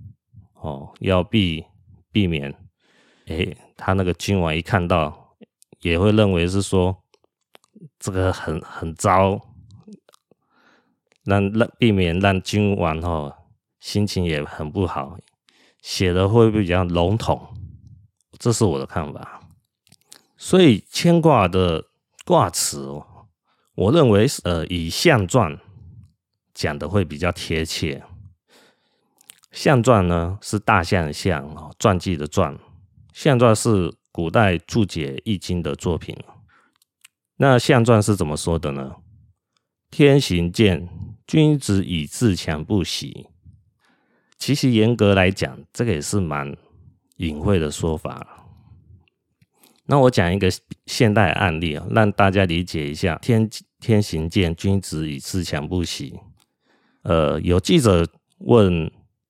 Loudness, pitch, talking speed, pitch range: -20 LUFS, 95 Hz, 170 characters per minute, 85-110 Hz